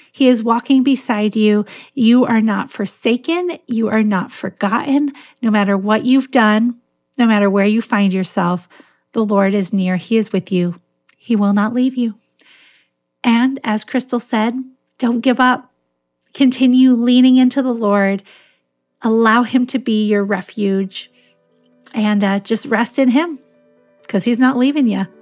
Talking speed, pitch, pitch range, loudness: 155 wpm, 220 Hz, 195-250 Hz, -15 LUFS